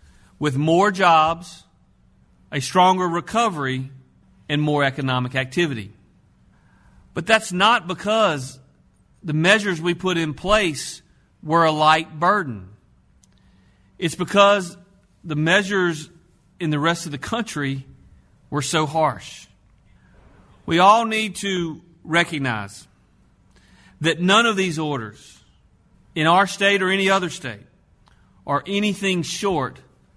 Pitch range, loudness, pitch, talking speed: 140-190 Hz, -20 LUFS, 165 Hz, 115 wpm